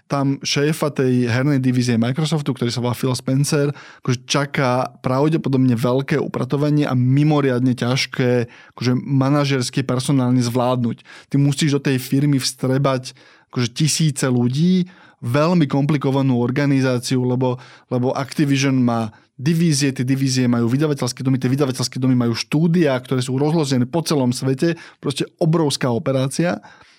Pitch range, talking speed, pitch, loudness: 125-145 Hz, 130 wpm, 135 Hz, -19 LUFS